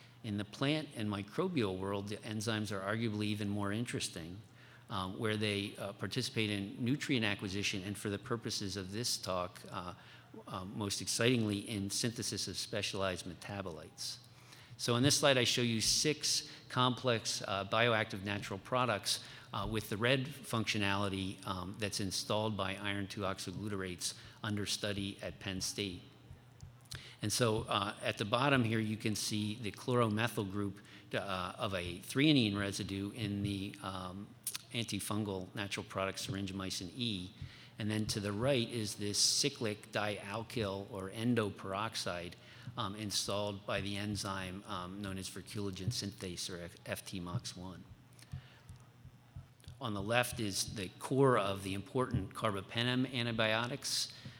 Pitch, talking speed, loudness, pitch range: 105 Hz, 140 wpm, -36 LUFS, 100-120 Hz